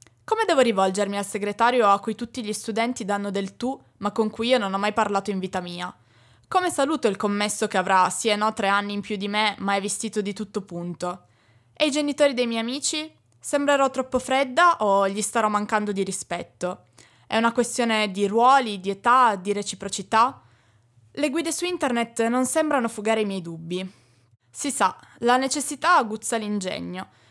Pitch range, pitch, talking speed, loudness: 195-250 Hz, 215 Hz, 185 wpm, -23 LUFS